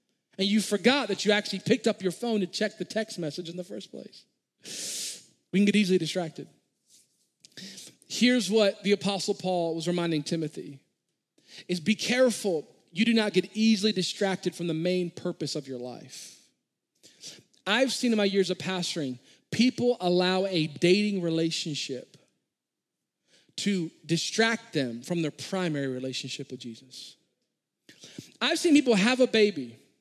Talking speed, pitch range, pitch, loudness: 150 wpm, 165-215 Hz, 185 Hz, -27 LUFS